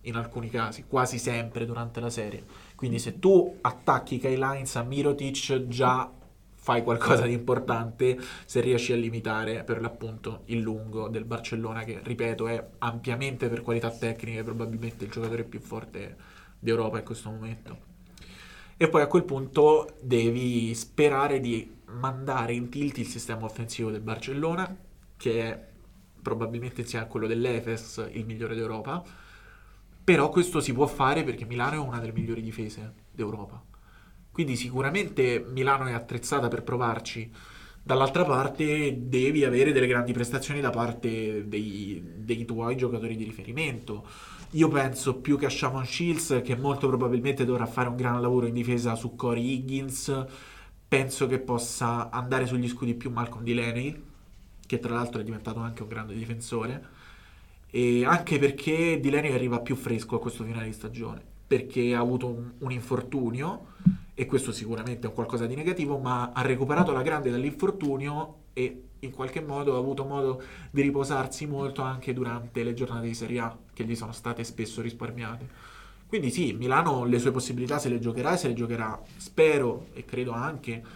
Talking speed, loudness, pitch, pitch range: 160 wpm, -28 LUFS, 120 Hz, 115-135 Hz